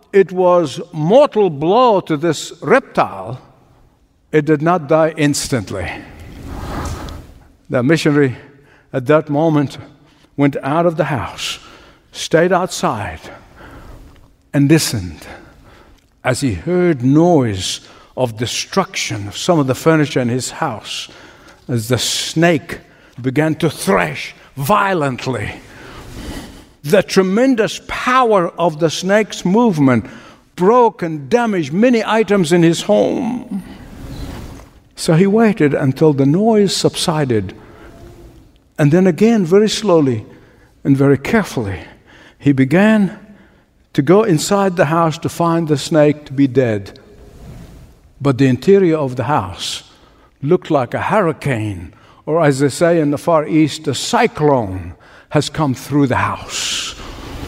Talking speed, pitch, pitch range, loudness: 120 wpm, 150 Hz, 135-180 Hz, -15 LUFS